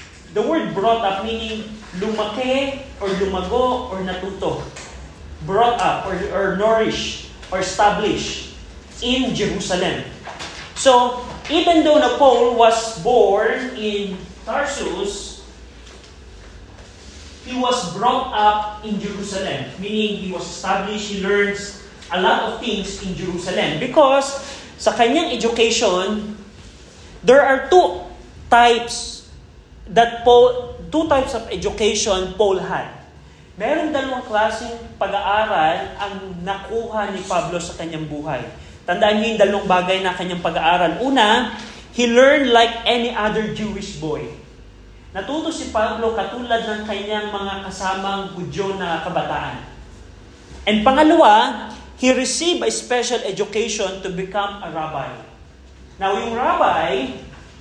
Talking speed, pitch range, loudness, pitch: 115 wpm, 185-235 Hz, -19 LUFS, 210 Hz